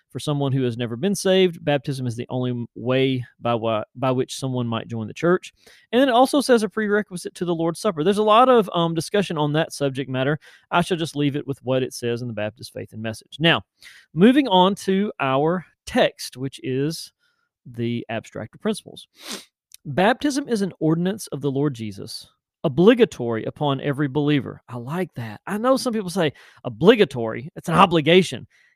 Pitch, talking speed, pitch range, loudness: 150 Hz, 195 wpm, 130-195 Hz, -21 LUFS